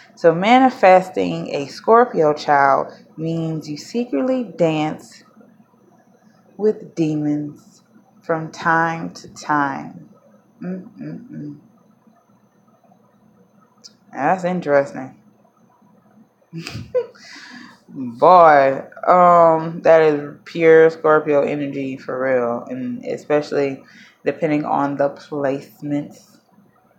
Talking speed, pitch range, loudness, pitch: 75 wpm, 150-225 Hz, -17 LUFS, 180 Hz